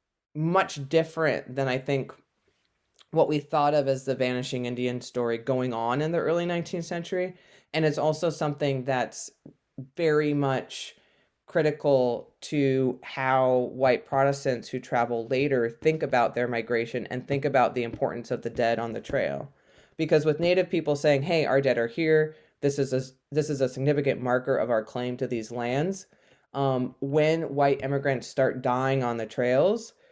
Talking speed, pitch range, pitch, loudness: 165 wpm, 125-155 Hz, 135 Hz, -26 LUFS